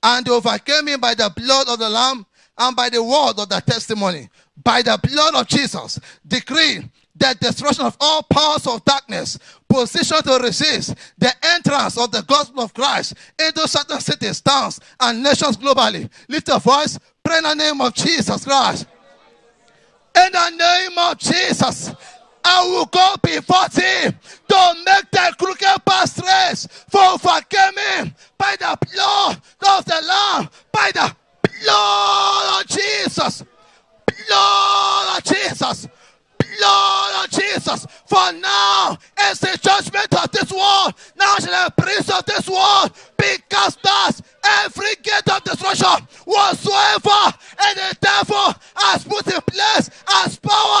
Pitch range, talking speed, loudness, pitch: 255-390 Hz, 145 wpm, -16 LUFS, 325 Hz